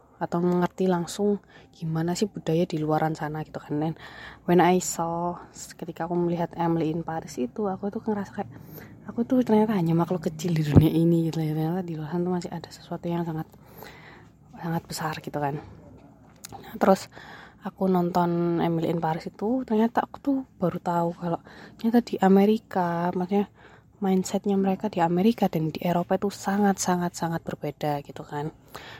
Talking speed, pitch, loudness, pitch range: 165 wpm, 175 Hz, -26 LUFS, 160-195 Hz